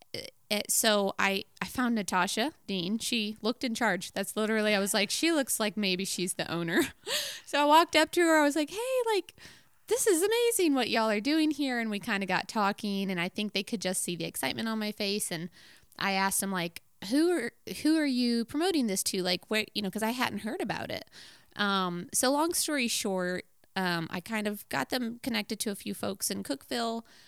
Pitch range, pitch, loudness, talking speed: 195-275 Hz, 215 Hz, -29 LUFS, 220 wpm